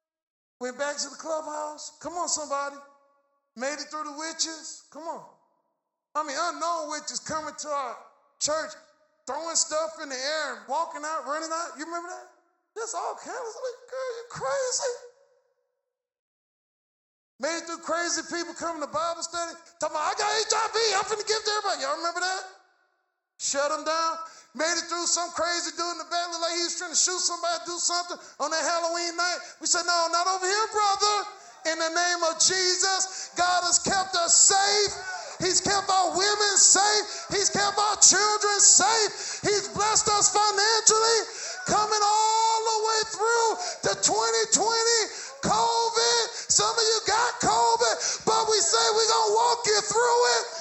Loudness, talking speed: -24 LUFS, 170 wpm